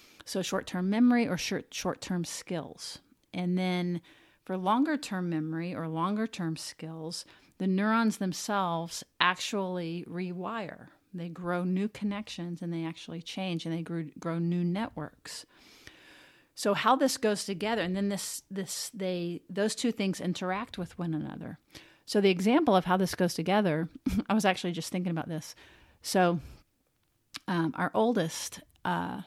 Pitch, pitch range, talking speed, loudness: 185 Hz, 170-205 Hz, 150 wpm, -31 LUFS